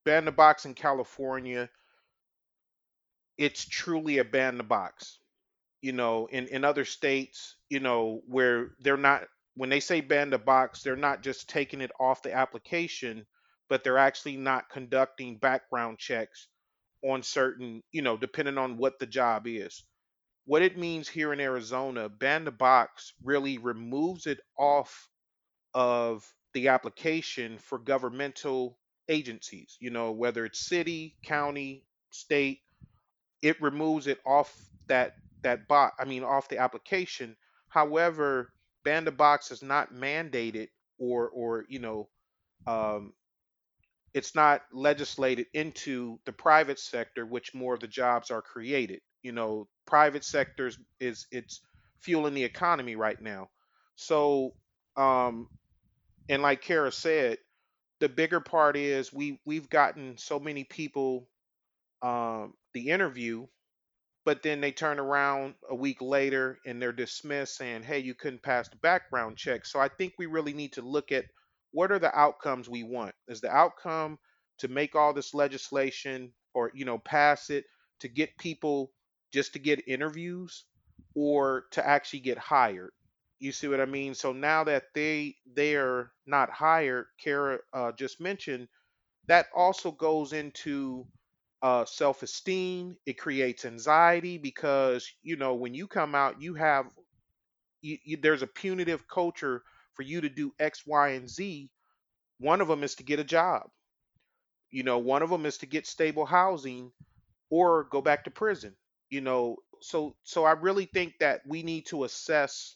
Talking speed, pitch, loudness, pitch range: 155 wpm, 140 Hz, -29 LUFS, 125-155 Hz